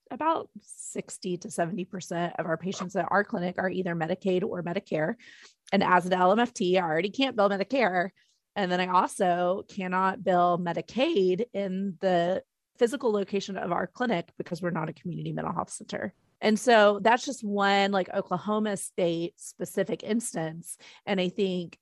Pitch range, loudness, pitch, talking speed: 180-210 Hz, -28 LUFS, 190 Hz, 160 wpm